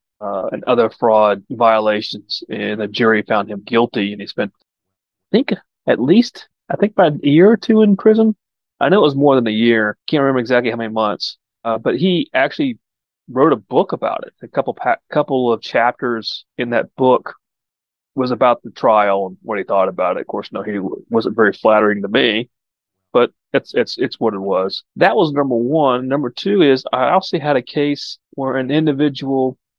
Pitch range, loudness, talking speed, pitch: 110-150 Hz, -16 LUFS, 205 wpm, 125 Hz